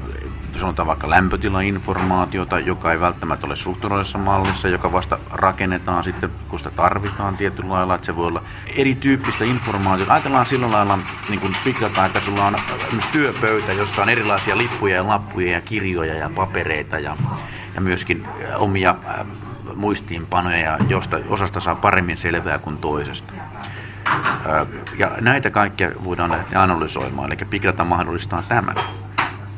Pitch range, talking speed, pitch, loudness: 90-105 Hz, 140 wpm, 95 Hz, -20 LUFS